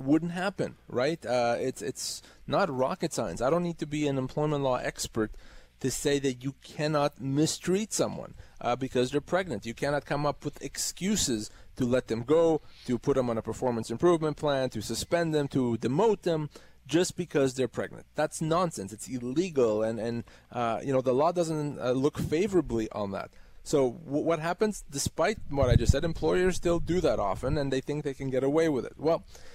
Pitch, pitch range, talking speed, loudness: 145 Hz, 125-165 Hz, 200 wpm, -29 LUFS